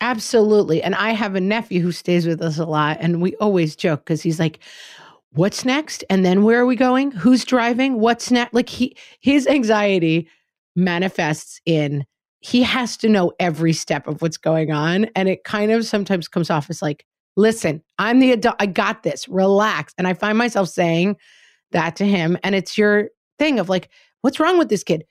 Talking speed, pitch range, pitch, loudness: 200 wpm, 165-230 Hz, 195 Hz, -19 LUFS